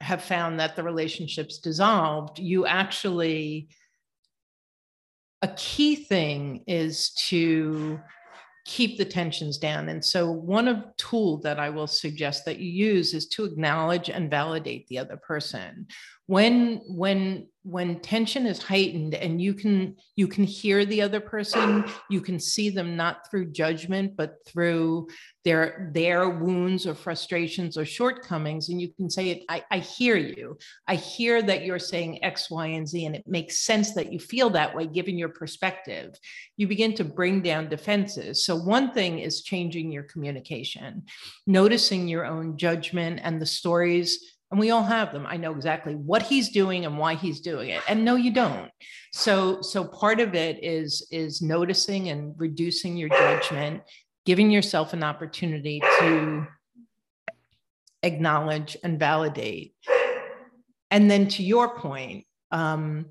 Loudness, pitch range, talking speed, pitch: -25 LUFS, 160-200 Hz, 155 wpm, 175 Hz